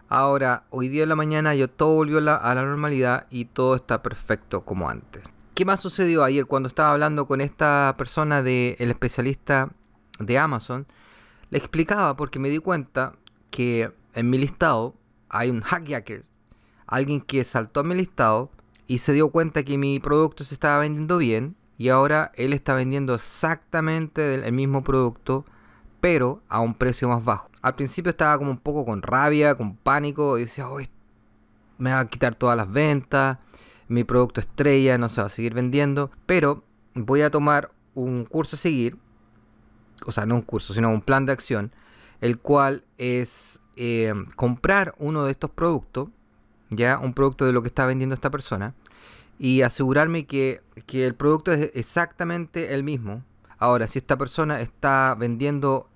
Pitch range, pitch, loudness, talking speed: 120-145 Hz, 130 Hz, -23 LUFS, 170 wpm